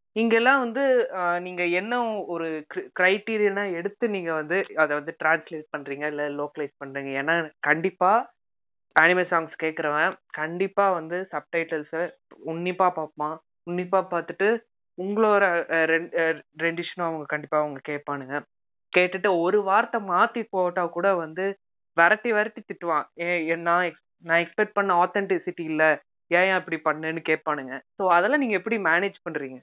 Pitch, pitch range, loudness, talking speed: 170 Hz, 155-195 Hz, -24 LUFS, 125 wpm